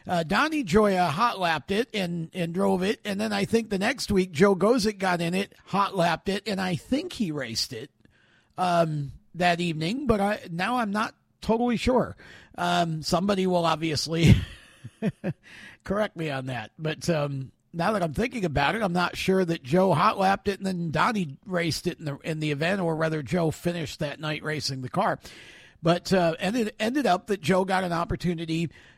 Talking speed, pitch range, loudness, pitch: 195 wpm, 160-200 Hz, -26 LUFS, 180 Hz